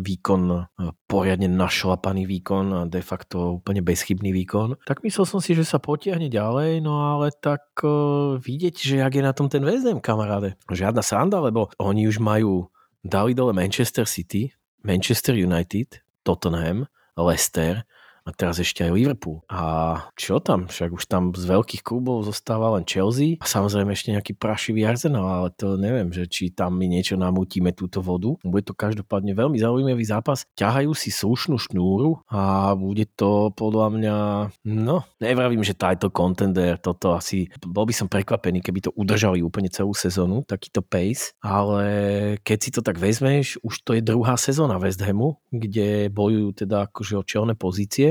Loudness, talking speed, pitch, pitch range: -23 LUFS, 165 wpm, 105 Hz, 95-120 Hz